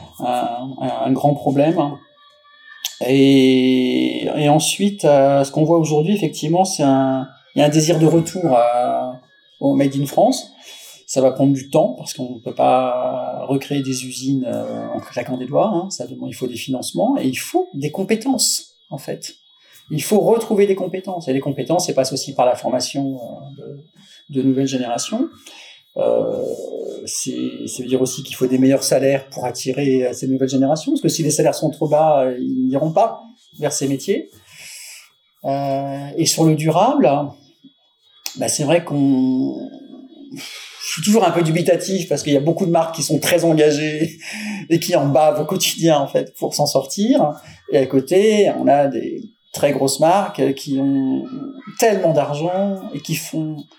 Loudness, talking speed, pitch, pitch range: -18 LUFS, 175 wpm, 150 Hz, 135-190 Hz